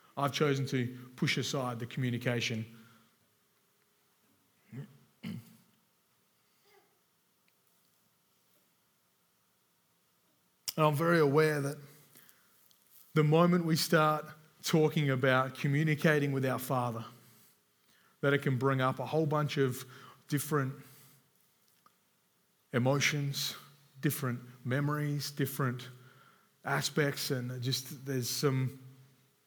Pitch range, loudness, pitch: 130-150 Hz, -32 LUFS, 140 Hz